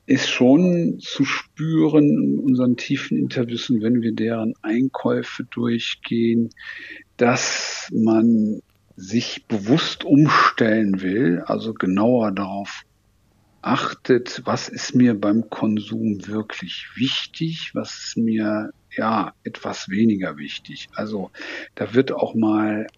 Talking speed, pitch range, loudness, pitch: 110 wpm, 105-120 Hz, -21 LUFS, 110 Hz